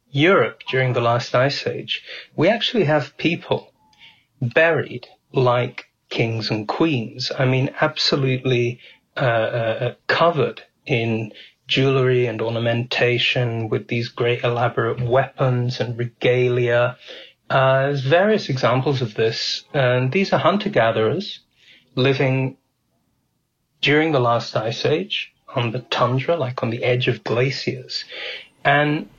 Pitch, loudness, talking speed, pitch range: 125 Hz, -20 LUFS, 120 wpm, 120-140 Hz